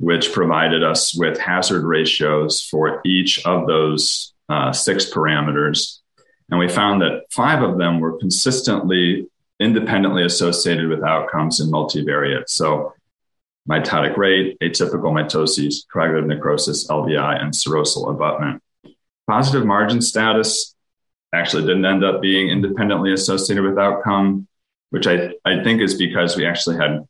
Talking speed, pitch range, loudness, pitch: 135 wpm, 80-100 Hz, -18 LUFS, 90 Hz